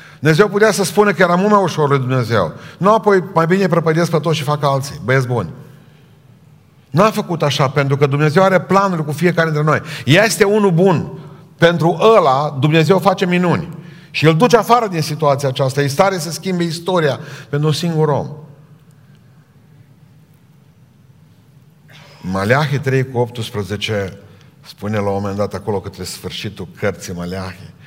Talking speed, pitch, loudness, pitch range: 160 wpm, 150 Hz, -15 LUFS, 140-175 Hz